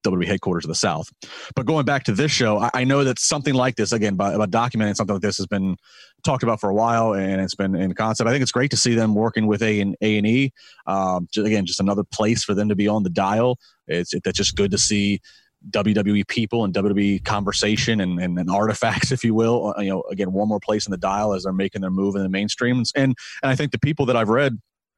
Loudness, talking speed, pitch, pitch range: -21 LUFS, 260 wpm, 105 Hz, 100-120 Hz